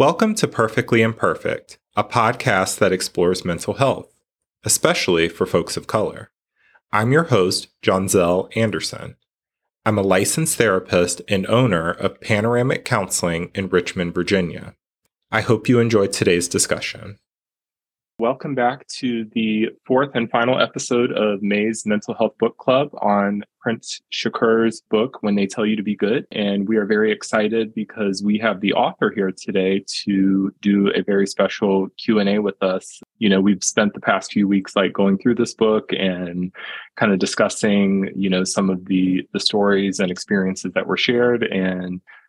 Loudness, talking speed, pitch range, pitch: -19 LUFS, 160 wpm, 95-115 Hz, 100 Hz